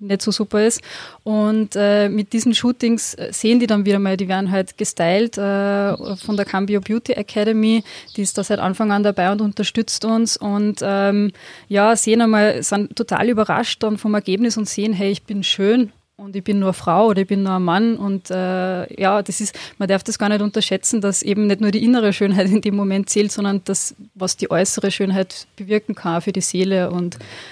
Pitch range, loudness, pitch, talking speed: 195-215 Hz, -18 LUFS, 205 Hz, 210 wpm